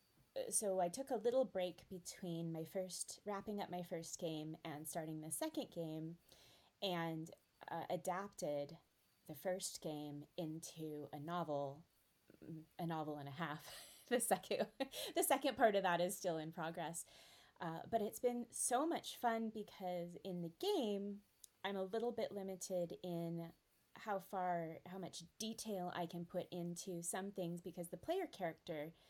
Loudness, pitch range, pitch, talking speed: -44 LUFS, 165-200 Hz, 180 Hz, 155 wpm